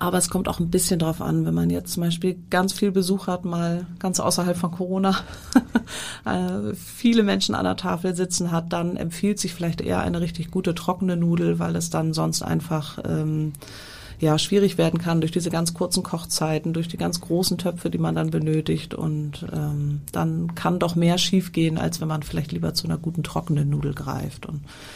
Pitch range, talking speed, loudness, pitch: 145-180 Hz, 195 wpm, -24 LUFS, 170 Hz